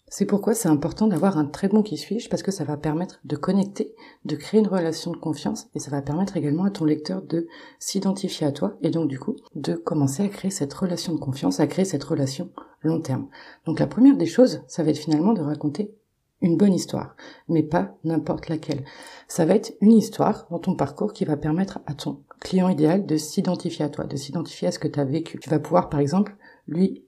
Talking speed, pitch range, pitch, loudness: 230 wpm, 150-195 Hz, 165 Hz, -24 LUFS